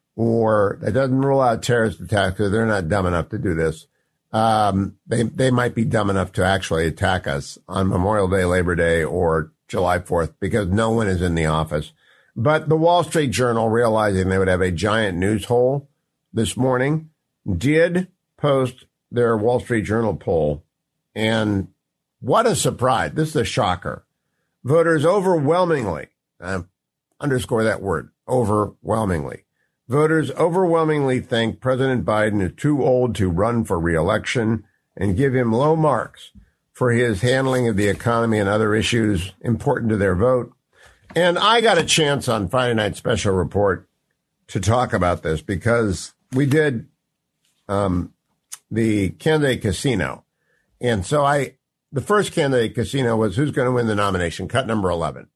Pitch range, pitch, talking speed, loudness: 100-130 Hz, 115 Hz, 160 wpm, -20 LUFS